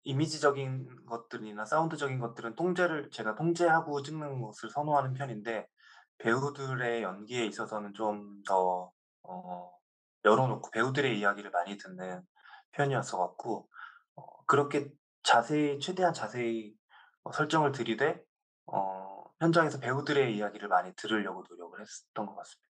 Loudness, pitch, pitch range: -32 LUFS, 125 Hz, 105-145 Hz